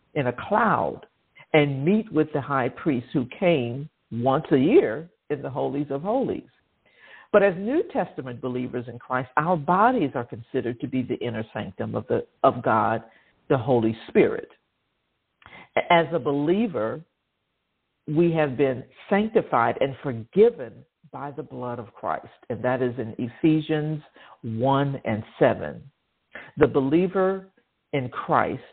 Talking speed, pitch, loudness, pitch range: 140 wpm, 145 Hz, -24 LUFS, 125-170 Hz